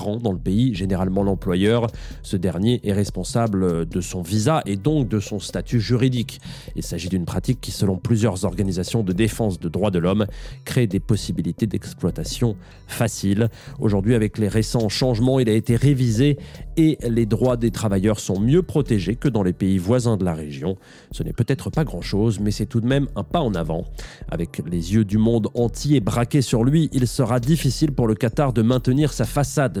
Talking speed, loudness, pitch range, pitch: 190 wpm, -21 LUFS, 100-130 Hz, 115 Hz